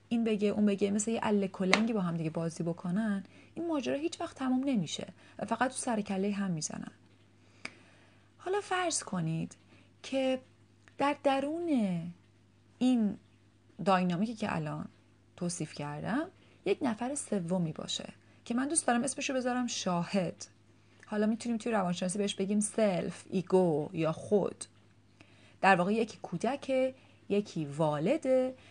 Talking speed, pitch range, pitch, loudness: 135 wpm, 170-250 Hz, 205 Hz, -32 LUFS